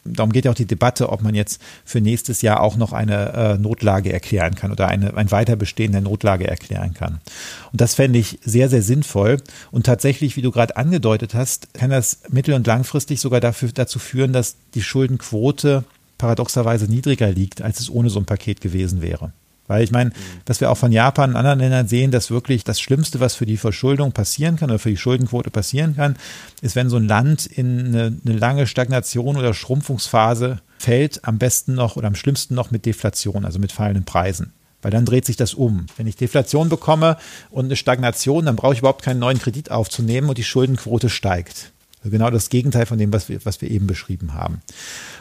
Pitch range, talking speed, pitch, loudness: 105-130 Hz, 205 wpm, 120 Hz, -19 LUFS